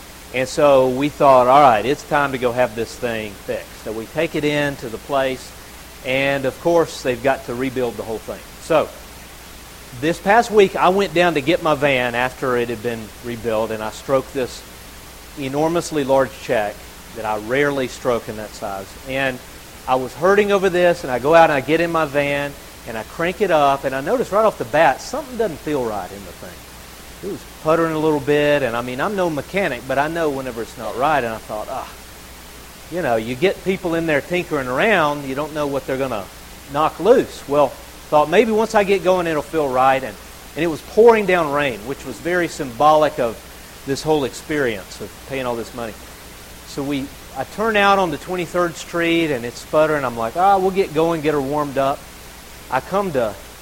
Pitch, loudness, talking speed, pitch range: 140 Hz, -19 LUFS, 220 wpm, 120-165 Hz